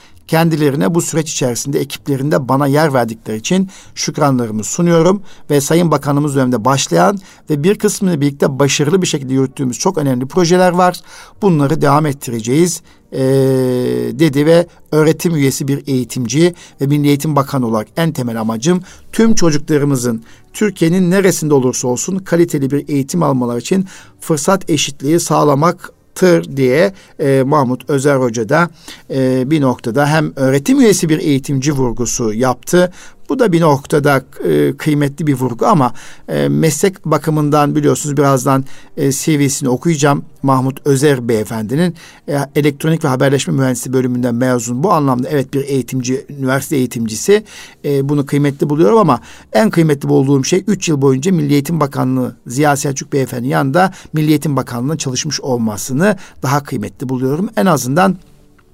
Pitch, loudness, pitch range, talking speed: 145 Hz, -14 LUFS, 130-165 Hz, 140 wpm